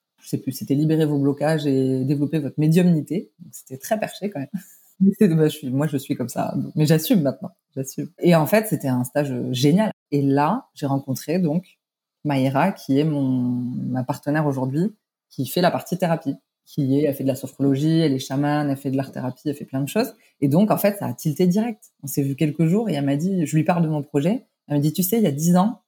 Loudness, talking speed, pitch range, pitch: -22 LUFS, 250 wpm, 140-180 Hz, 150 Hz